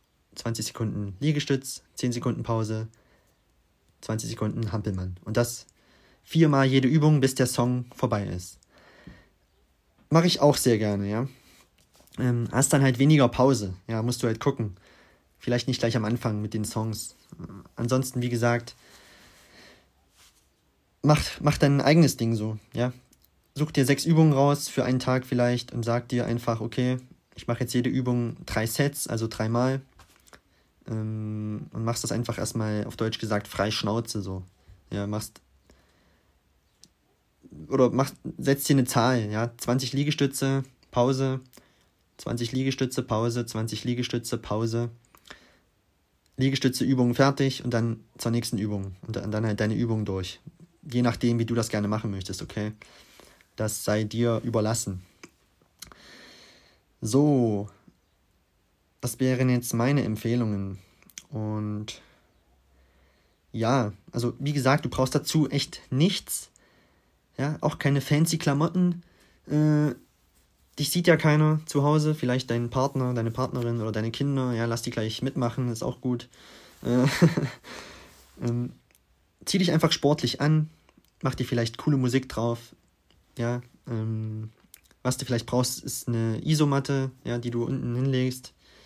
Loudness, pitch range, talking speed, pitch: -26 LUFS, 105-135 Hz, 135 wpm, 120 Hz